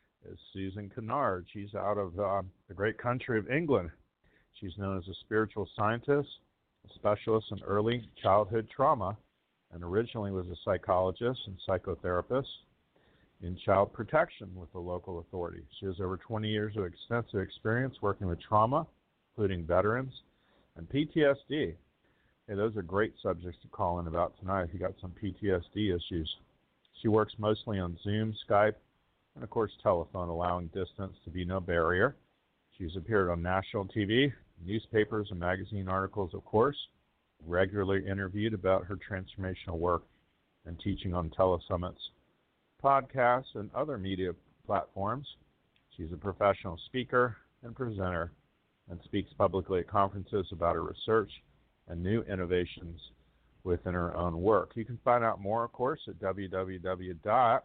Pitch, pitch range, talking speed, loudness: 95 Hz, 90-110 Hz, 145 wpm, -32 LUFS